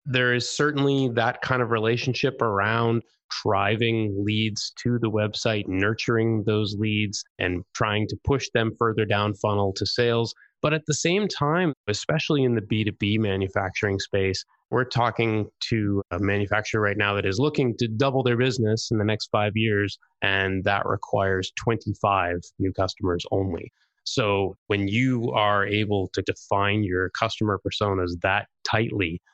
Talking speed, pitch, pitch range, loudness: 155 wpm, 105 Hz, 100-120 Hz, -24 LUFS